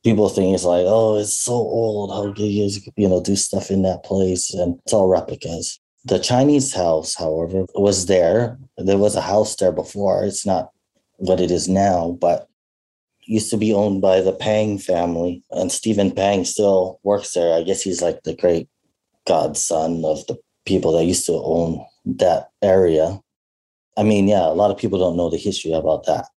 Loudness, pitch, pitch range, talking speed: -19 LUFS, 95 Hz, 85-105 Hz, 195 wpm